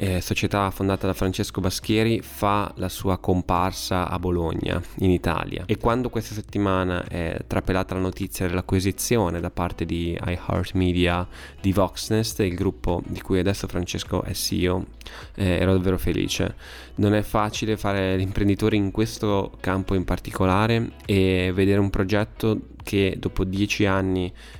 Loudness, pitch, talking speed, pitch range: -24 LUFS, 95 Hz, 145 wpm, 90-105 Hz